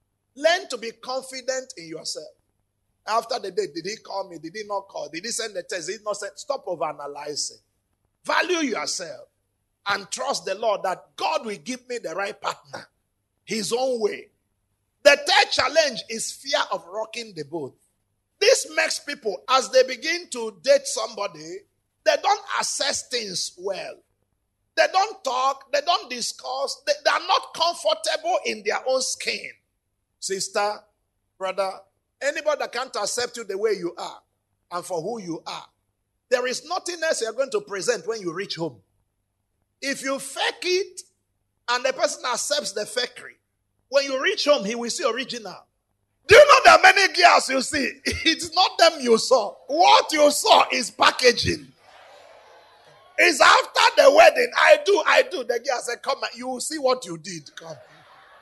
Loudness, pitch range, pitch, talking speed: -22 LUFS, 210-330 Hz, 265 Hz, 175 wpm